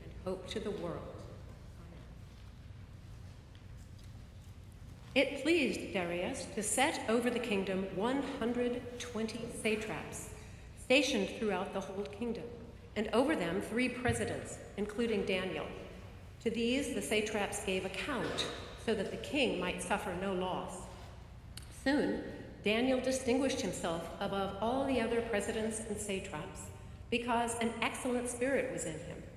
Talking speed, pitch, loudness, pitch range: 120 wpm, 215 Hz, -35 LUFS, 185-245 Hz